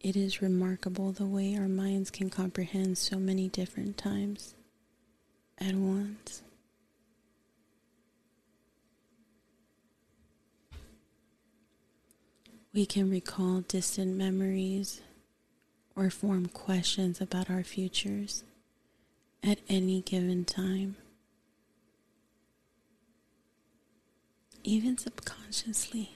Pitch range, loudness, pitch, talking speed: 185-200 Hz, -32 LUFS, 190 Hz, 75 wpm